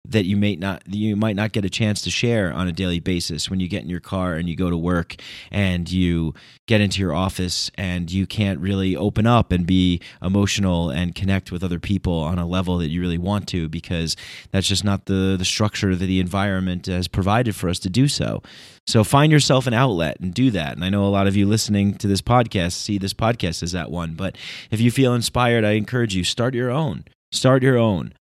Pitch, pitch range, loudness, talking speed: 95 Hz, 90-110 Hz, -21 LUFS, 235 wpm